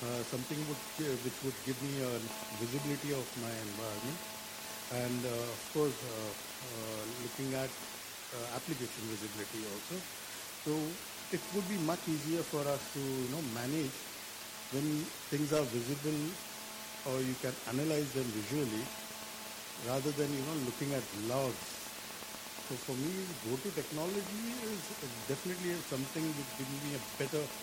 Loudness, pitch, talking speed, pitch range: -38 LUFS, 135 Hz, 150 wpm, 120-155 Hz